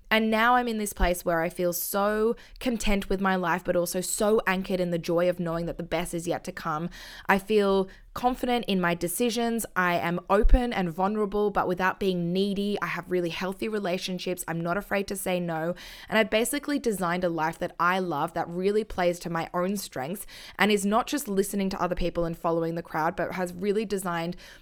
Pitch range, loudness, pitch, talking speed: 175-205 Hz, -27 LUFS, 185 Hz, 215 wpm